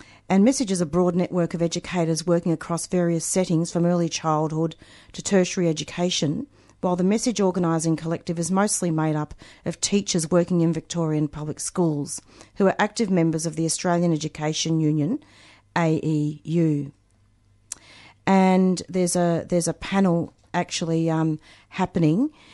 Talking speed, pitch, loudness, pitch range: 140 wpm, 170 Hz, -23 LUFS, 155-180 Hz